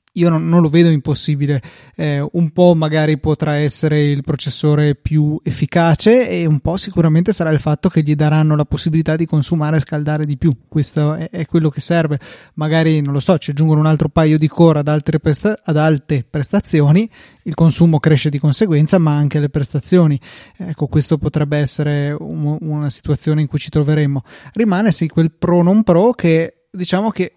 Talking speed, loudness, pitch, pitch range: 190 wpm, -15 LUFS, 155 Hz, 150-165 Hz